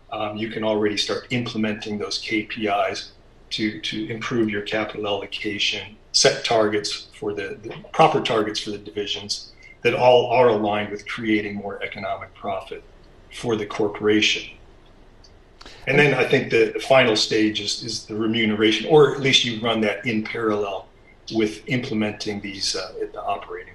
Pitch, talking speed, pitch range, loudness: 110 Hz, 160 wpm, 105-115 Hz, -22 LUFS